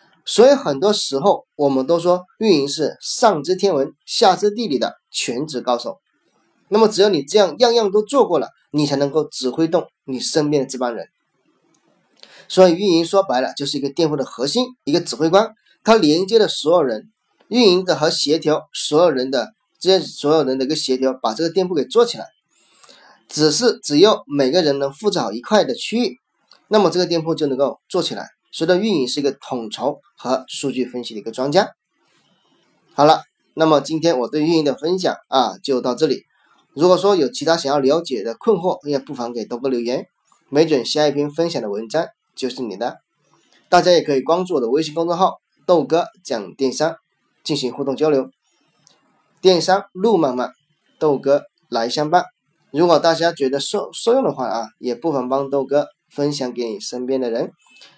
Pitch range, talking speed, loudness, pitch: 135-185 Hz, 280 characters per minute, -18 LUFS, 155 Hz